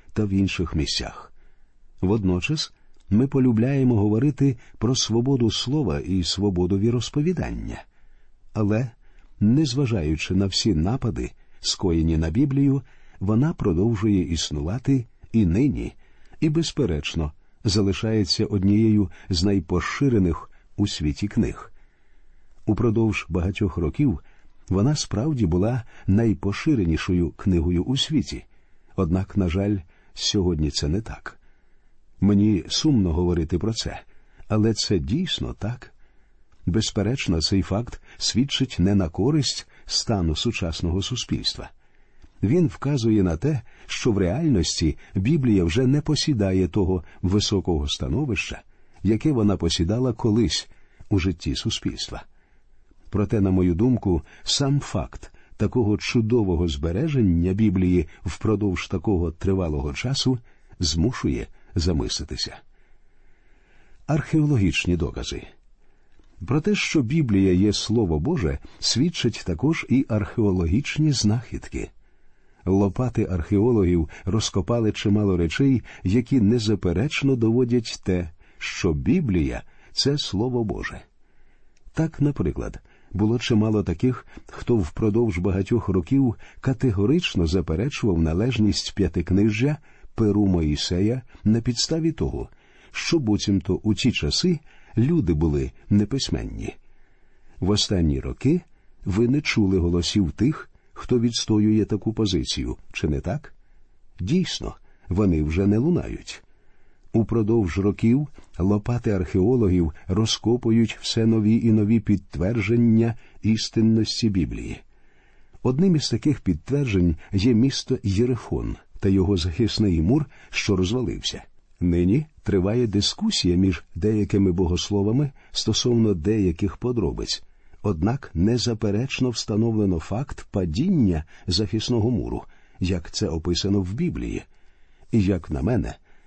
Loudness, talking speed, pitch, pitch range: -23 LUFS, 105 wpm, 105 Hz, 90-120 Hz